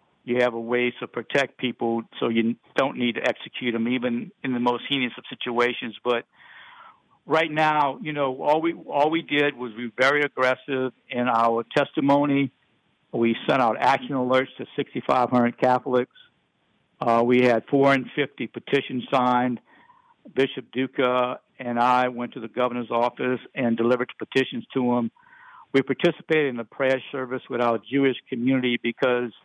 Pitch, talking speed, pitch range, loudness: 125 Hz, 160 wpm, 120-135 Hz, -24 LUFS